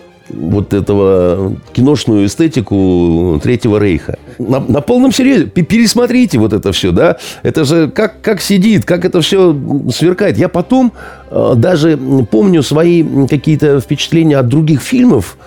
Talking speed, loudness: 135 wpm, -10 LUFS